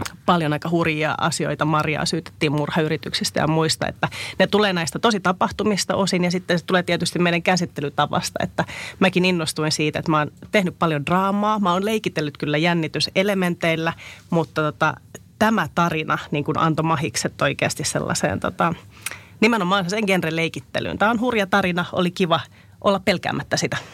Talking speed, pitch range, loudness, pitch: 155 wpm, 155-190 Hz, -21 LUFS, 170 Hz